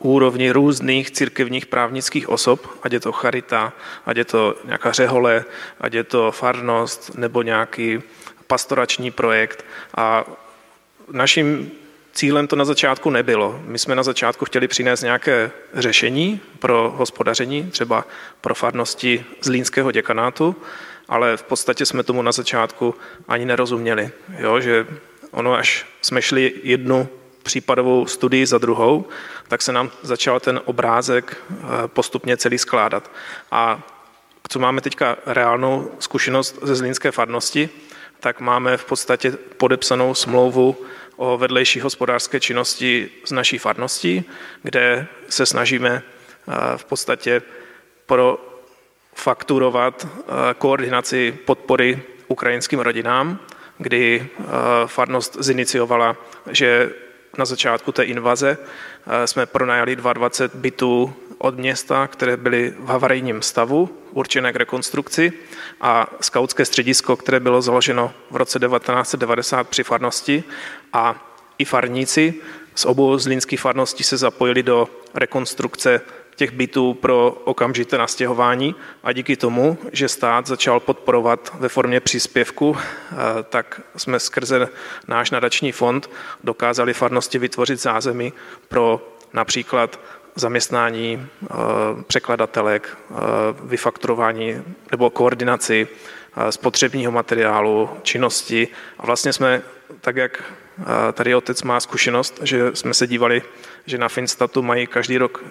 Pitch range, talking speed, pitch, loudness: 120-130 Hz, 115 wpm, 125 Hz, -19 LUFS